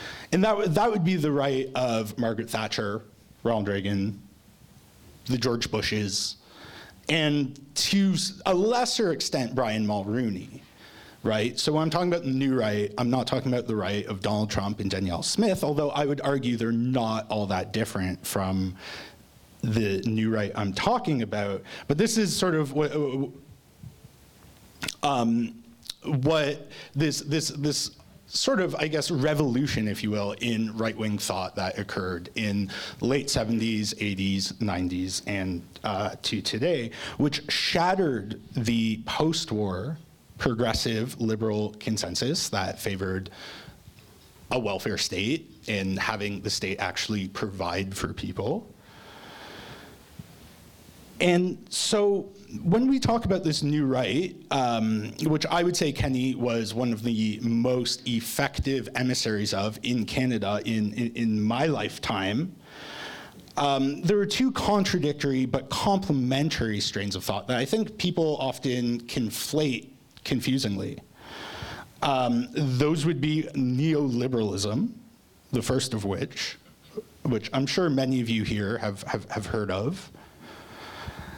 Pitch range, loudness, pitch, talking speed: 105-145 Hz, -27 LUFS, 120 Hz, 135 wpm